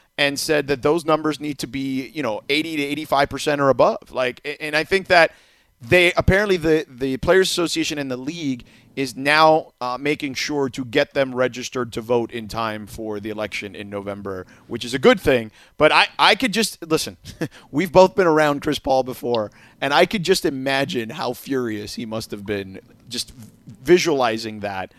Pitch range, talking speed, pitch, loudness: 120-155 Hz, 190 wpm, 135 Hz, -20 LUFS